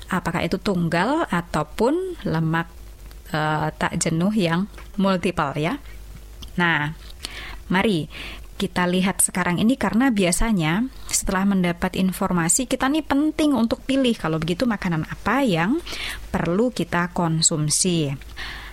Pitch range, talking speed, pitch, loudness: 165-220 Hz, 110 wpm, 185 Hz, -22 LUFS